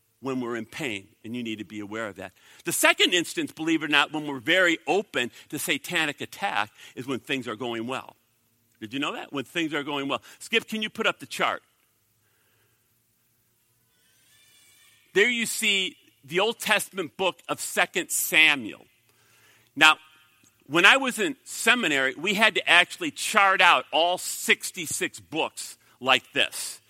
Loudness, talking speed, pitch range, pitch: -24 LUFS, 165 wpm, 115-195 Hz, 150 Hz